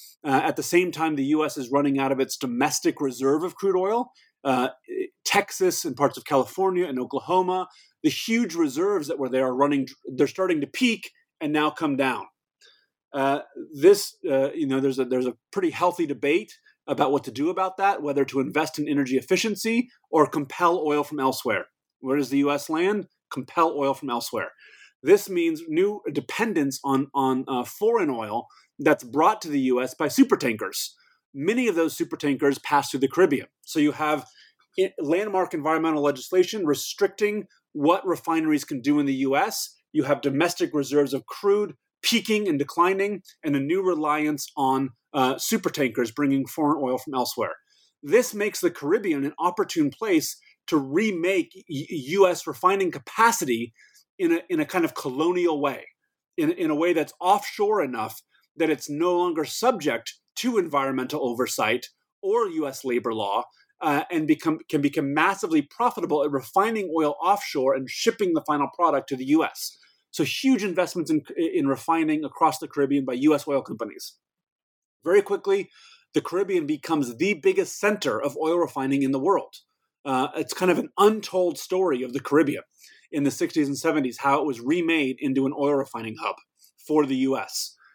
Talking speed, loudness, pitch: 170 wpm, -24 LUFS, 170 Hz